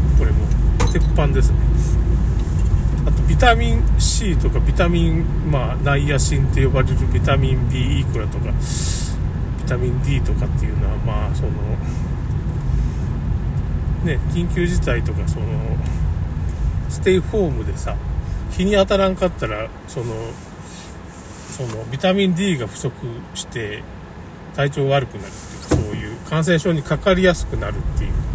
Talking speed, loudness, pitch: 270 characters per minute, -19 LUFS, 105 Hz